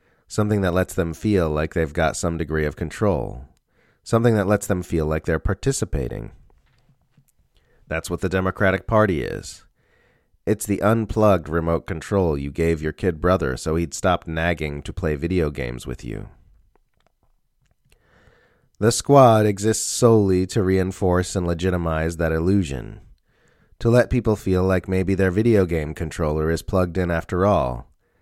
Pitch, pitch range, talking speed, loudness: 90 Hz, 80-100 Hz, 150 wpm, -21 LUFS